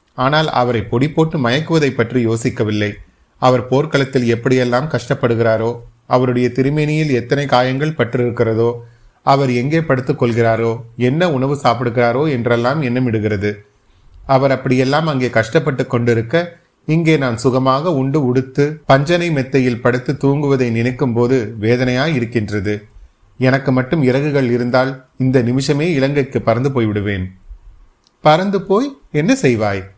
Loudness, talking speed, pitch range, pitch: -16 LUFS, 110 wpm, 120-140 Hz, 125 Hz